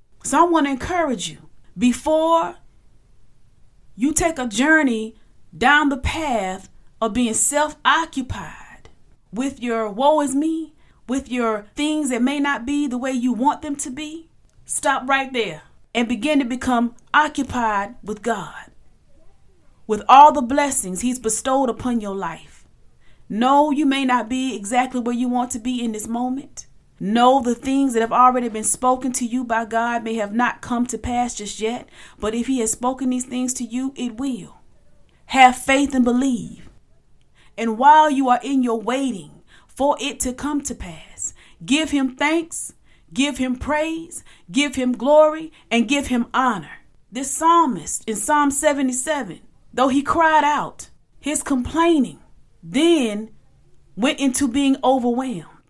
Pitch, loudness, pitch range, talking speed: 255 Hz, -20 LUFS, 235-285 Hz, 155 wpm